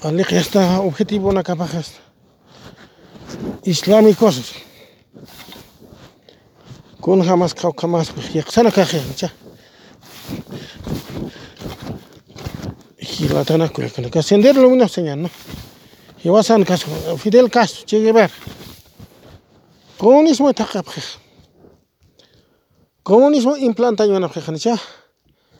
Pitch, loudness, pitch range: 190 Hz, -15 LUFS, 170-225 Hz